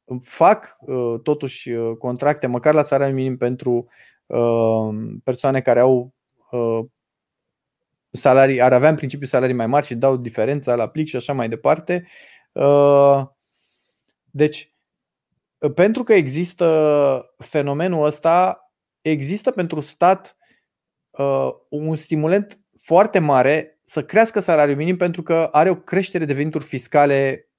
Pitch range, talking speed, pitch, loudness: 125-160 Hz, 115 wpm, 145 Hz, -18 LUFS